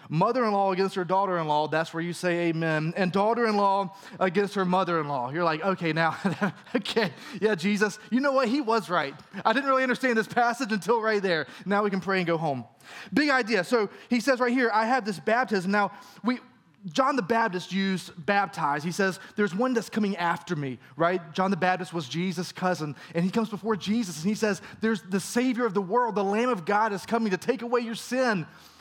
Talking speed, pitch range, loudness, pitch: 210 wpm, 175-230 Hz, -26 LUFS, 200 Hz